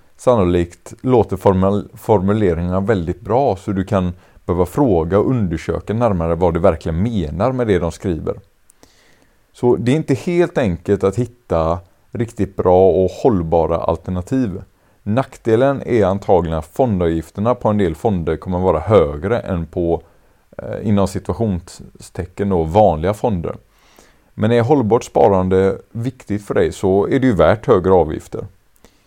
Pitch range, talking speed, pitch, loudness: 90-115 Hz, 140 wpm, 95 Hz, -17 LUFS